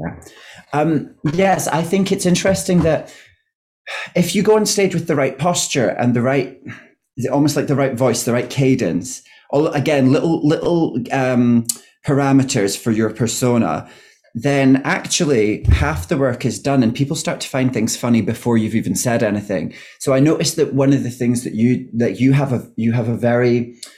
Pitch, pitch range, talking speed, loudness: 135 Hz, 120-160 Hz, 185 wpm, -17 LUFS